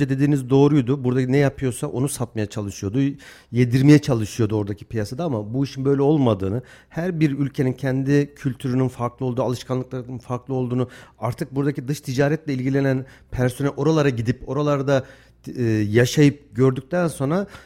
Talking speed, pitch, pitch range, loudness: 135 wpm, 135 Hz, 125-140 Hz, -22 LUFS